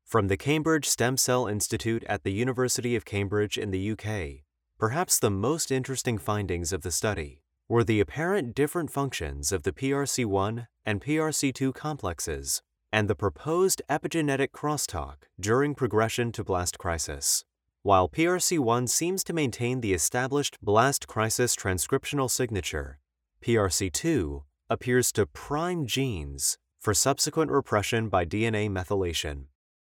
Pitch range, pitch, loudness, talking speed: 95-135 Hz, 115 Hz, -27 LUFS, 130 wpm